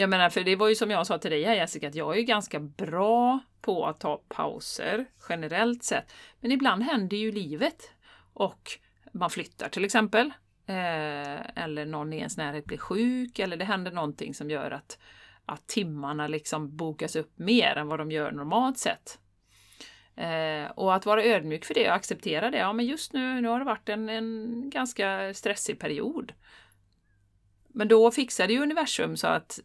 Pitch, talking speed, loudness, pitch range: 200 Hz, 180 wpm, -28 LUFS, 155-225 Hz